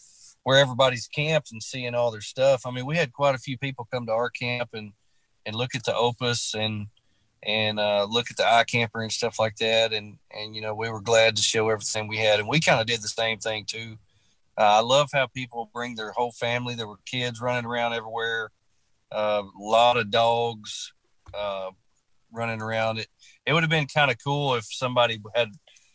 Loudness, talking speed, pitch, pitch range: -25 LUFS, 215 wpm, 115 Hz, 110-125 Hz